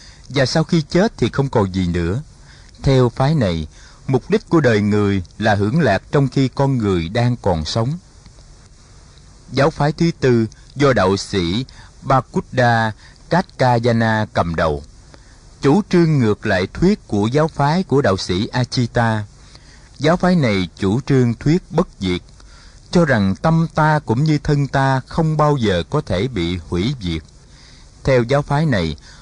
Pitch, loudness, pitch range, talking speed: 125 Hz, -18 LUFS, 100-150 Hz, 160 wpm